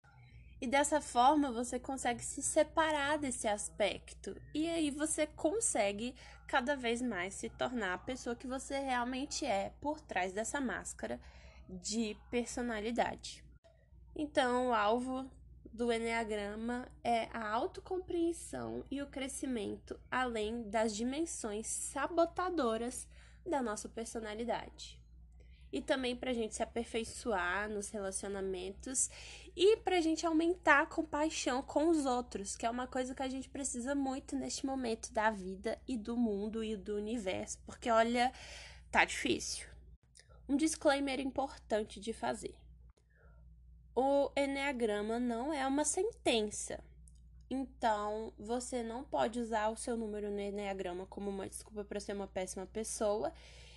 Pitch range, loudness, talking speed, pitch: 210-280 Hz, -36 LUFS, 130 wpm, 240 Hz